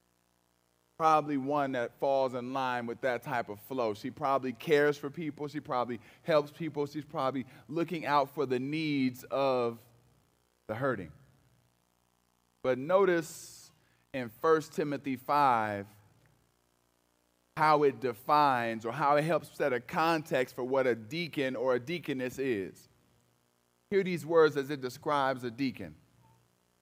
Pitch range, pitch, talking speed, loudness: 100-150 Hz, 130 Hz, 140 wpm, -31 LUFS